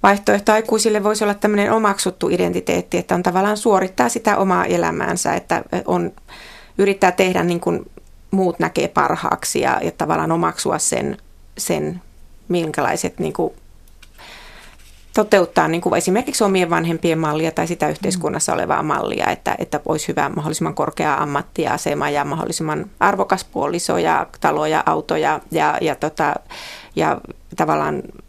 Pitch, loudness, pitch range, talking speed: 190 Hz, -19 LUFS, 170-210 Hz, 135 wpm